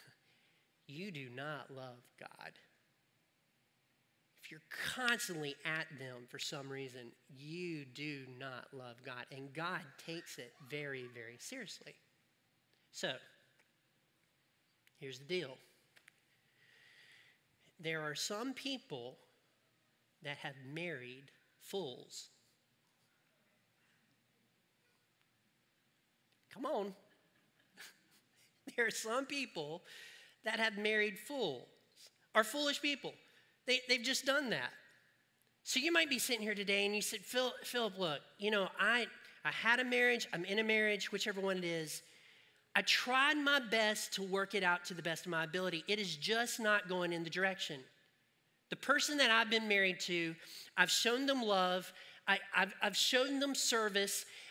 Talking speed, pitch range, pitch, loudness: 135 wpm, 155-235 Hz, 195 Hz, -36 LUFS